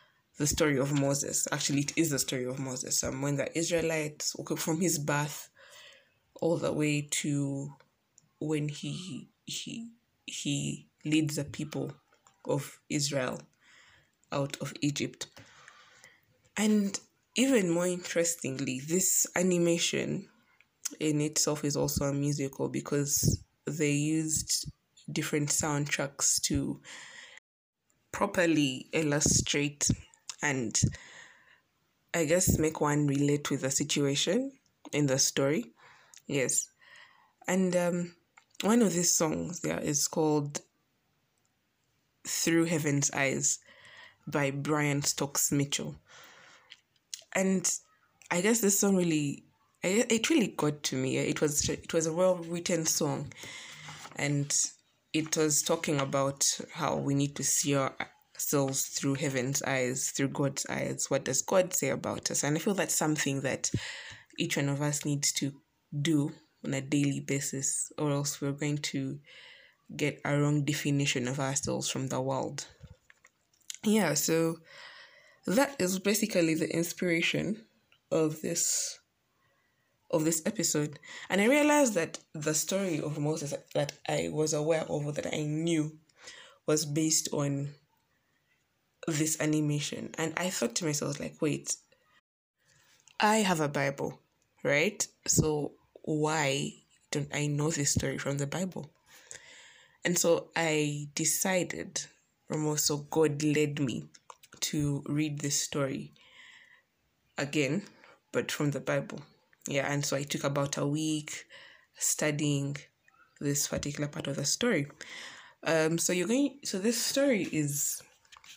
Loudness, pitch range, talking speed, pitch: -30 LUFS, 140-170 Hz, 130 wpm, 150 Hz